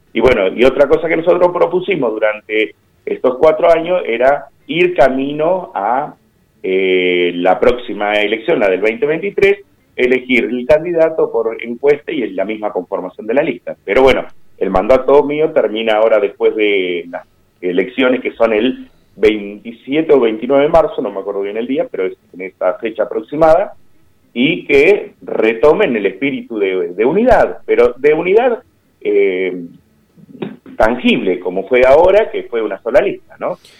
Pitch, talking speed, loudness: 140 Hz, 160 wpm, -14 LUFS